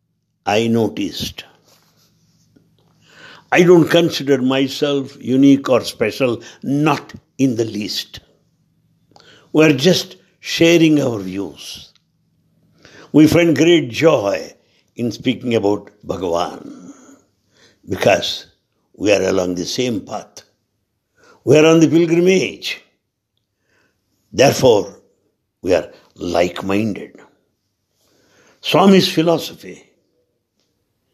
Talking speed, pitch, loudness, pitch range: 85 wpm, 145 Hz, -16 LUFS, 115-165 Hz